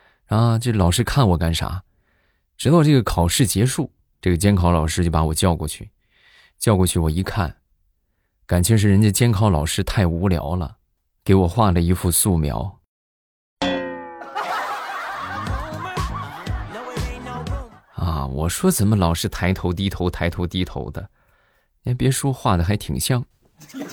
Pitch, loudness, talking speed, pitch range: 90 Hz, -20 LUFS, 200 characters per minute, 85-105 Hz